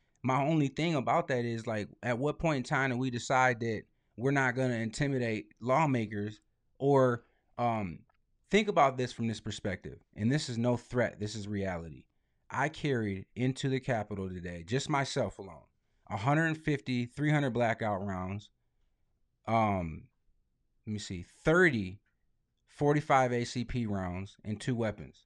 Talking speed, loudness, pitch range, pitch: 145 wpm, -32 LUFS, 105-135 Hz, 120 Hz